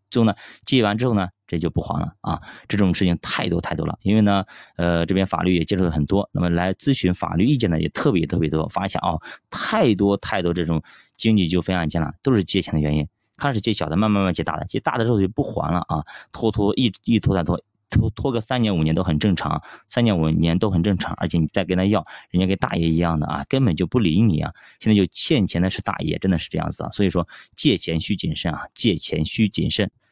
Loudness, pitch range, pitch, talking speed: -21 LUFS, 85-105 Hz, 95 Hz, 355 characters per minute